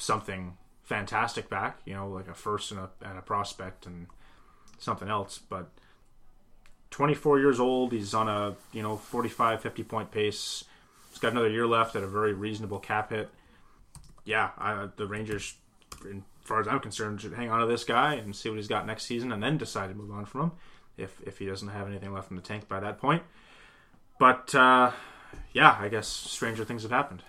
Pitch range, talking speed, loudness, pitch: 100-115 Hz, 200 wpm, -29 LUFS, 105 Hz